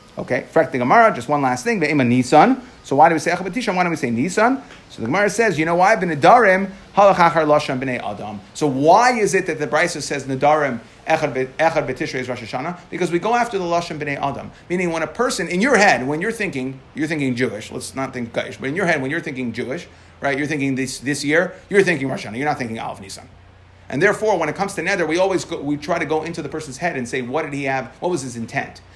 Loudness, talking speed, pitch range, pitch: -19 LUFS, 225 wpm, 130-180 Hz, 155 Hz